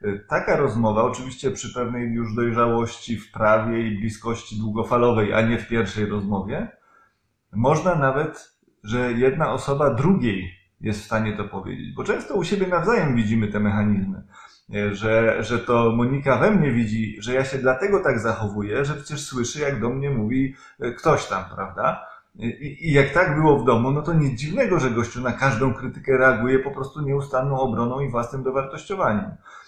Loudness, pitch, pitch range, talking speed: -22 LUFS, 120 Hz, 110-135 Hz, 170 wpm